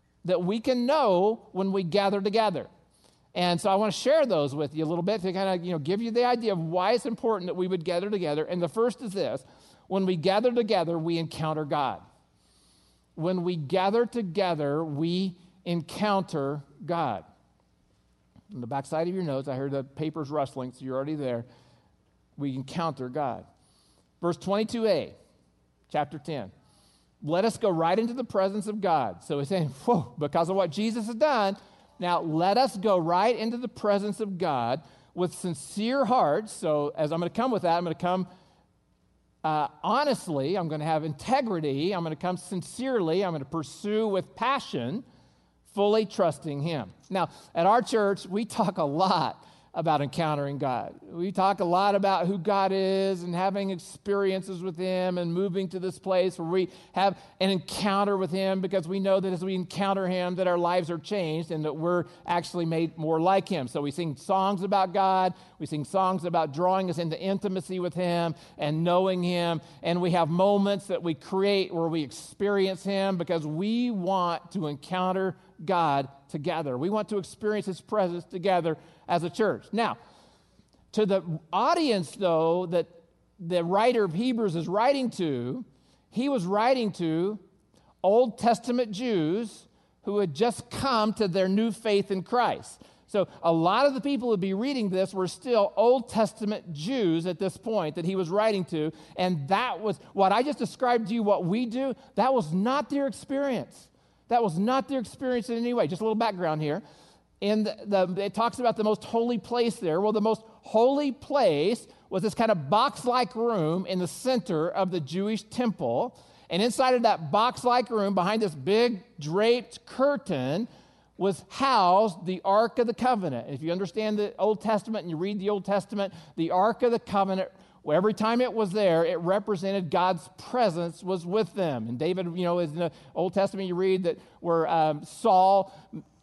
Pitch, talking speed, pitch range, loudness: 190 Hz, 185 wpm, 170-215 Hz, -27 LUFS